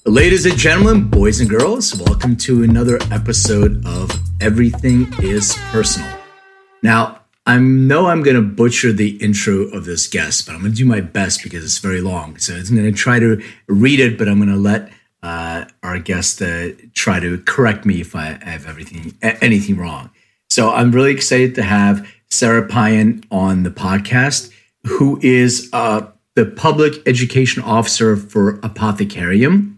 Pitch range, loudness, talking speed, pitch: 100-125 Hz, -14 LUFS, 170 wpm, 110 Hz